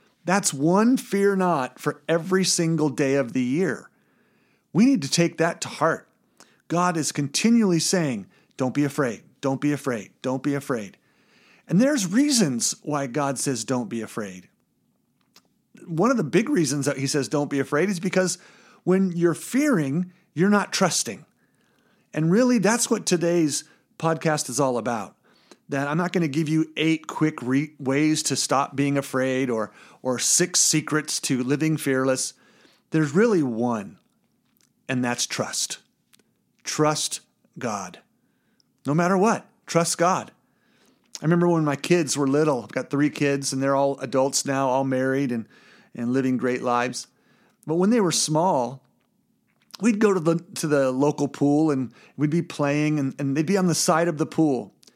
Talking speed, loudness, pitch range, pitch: 165 wpm, -23 LUFS, 140-185 Hz, 155 Hz